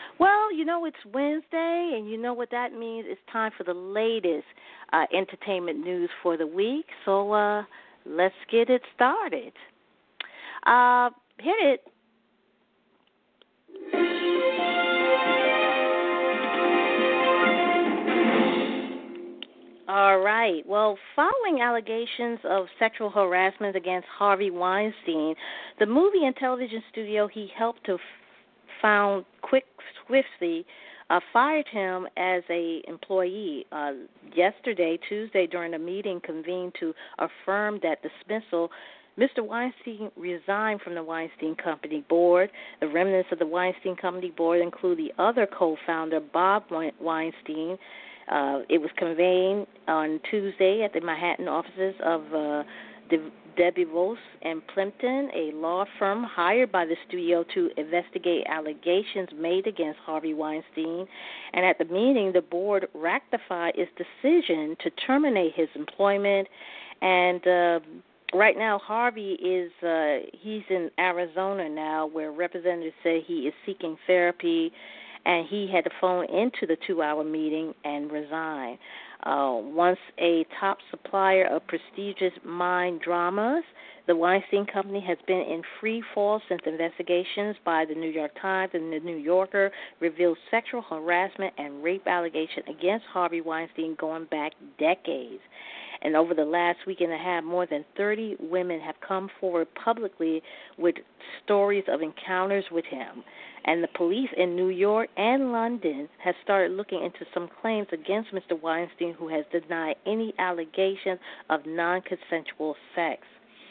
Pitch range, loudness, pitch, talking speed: 165-210 Hz, -26 LUFS, 185 Hz, 135 wpm